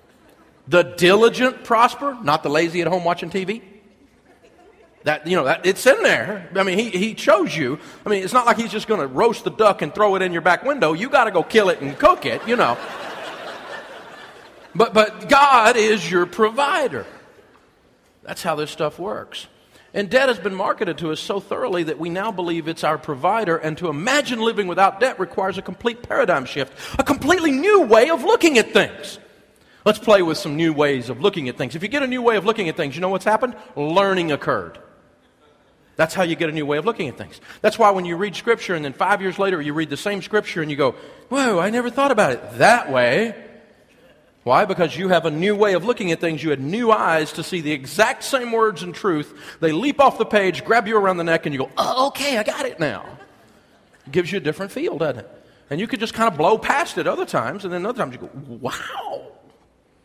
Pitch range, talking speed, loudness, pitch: 165-230 Hz, 230 wpm, -19 LUFS, 195 Hz